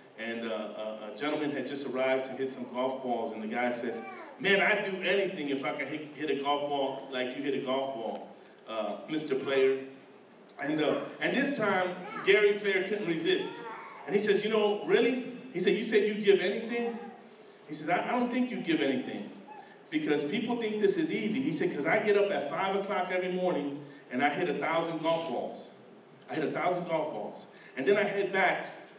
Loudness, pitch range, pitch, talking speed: -30 LUFS, 135-215 Hz, 180 Hz, 215 wpm